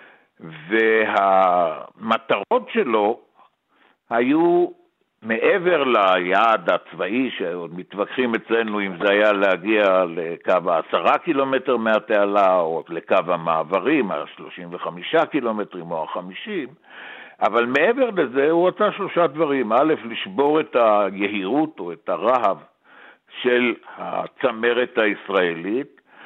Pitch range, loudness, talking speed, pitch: 105-170 Hz, -20 LUFS, 95 wpm, 125 Hz